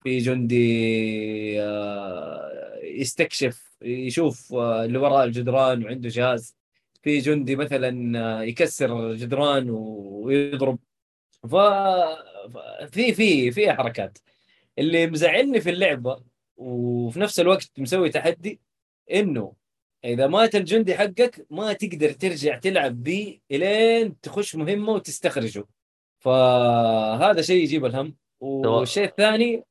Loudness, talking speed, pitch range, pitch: -22 LUFS, 95 wpm, 120-185 Hz, 135 Hz